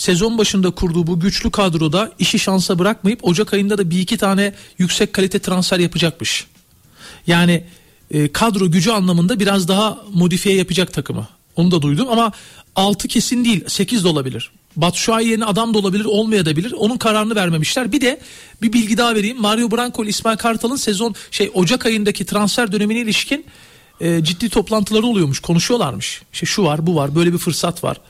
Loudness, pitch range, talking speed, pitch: -16 LUFS, 175-225 Hz, 170 wpm, 200 Hz